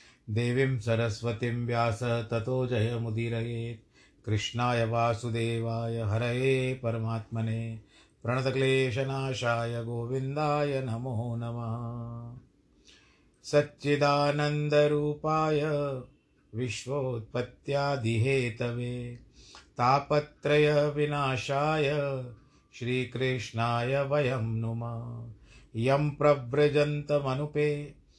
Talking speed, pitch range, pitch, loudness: 45 wpm, 115-145 Hz, 125 Hz, -29 LUFS